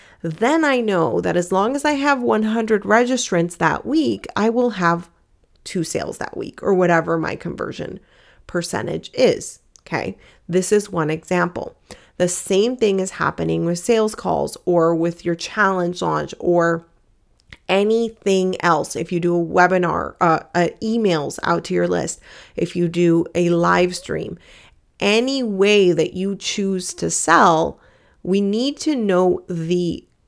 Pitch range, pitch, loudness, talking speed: 170-215 Hz, 180 Hz, -19 LUFS, 155 wpm